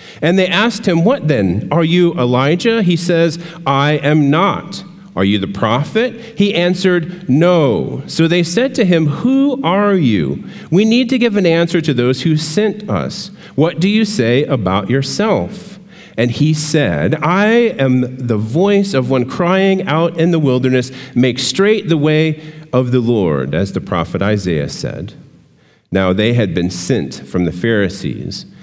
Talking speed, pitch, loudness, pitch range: 170 wpm, 165 Hz, -14 LUFS, 130-195 Hz